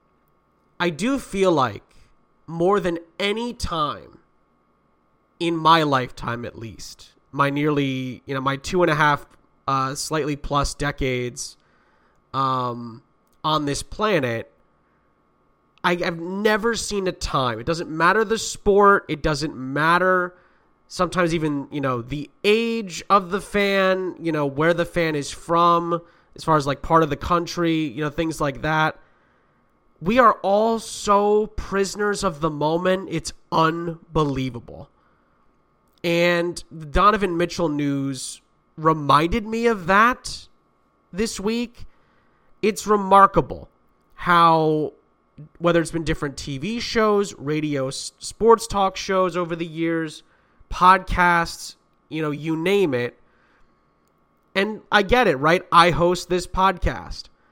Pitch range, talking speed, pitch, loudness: 145-190 Hz, 130 wpm, 170 Hz, -21 LUFS